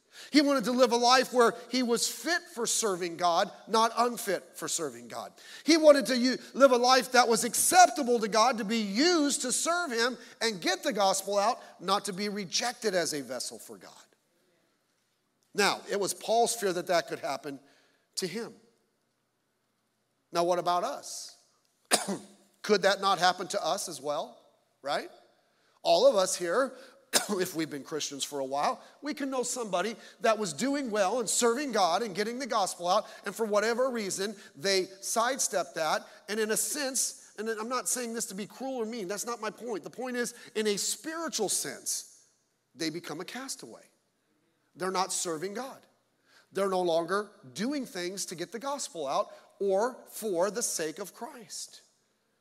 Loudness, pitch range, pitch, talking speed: -29 LUFS, 185-245 Hz, 220 Hz, 180 wpm